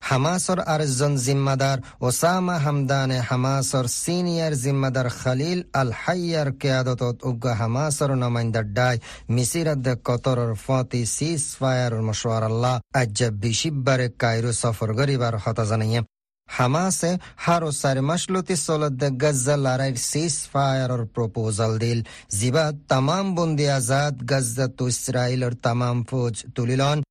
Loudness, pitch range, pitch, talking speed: -23 LUFS, 120-145 Hz, 130 Hz, 135 wpm